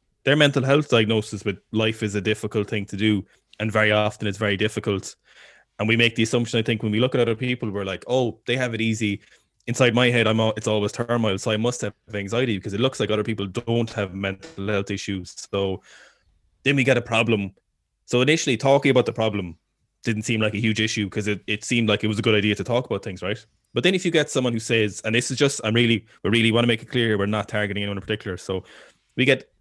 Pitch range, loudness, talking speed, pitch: 105-120 Hz, -22 LUFS, 255 wpm, 110 Hz